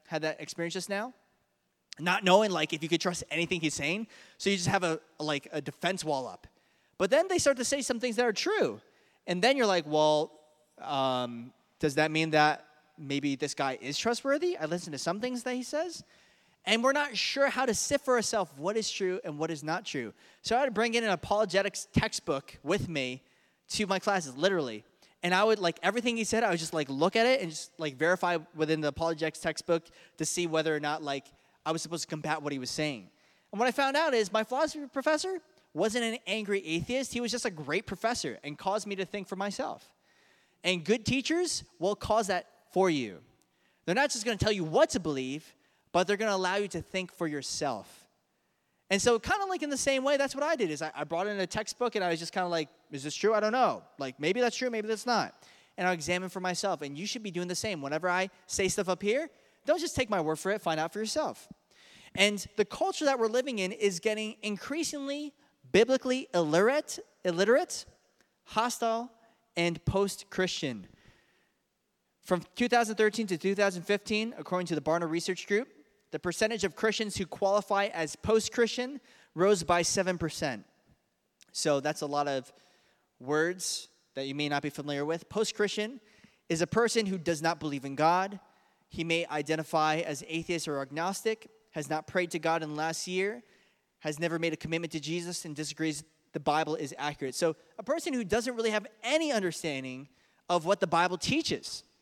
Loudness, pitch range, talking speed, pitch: -30 LUFS, 160-225 Hz, 210 wpm, 185 Hz